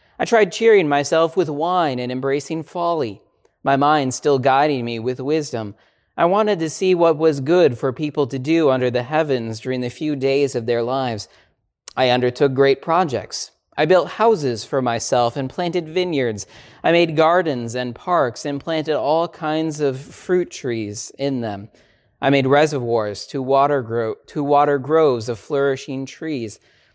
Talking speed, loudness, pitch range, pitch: 165 wpm, -19 LUFS, 125-160 Hz, 140 Hz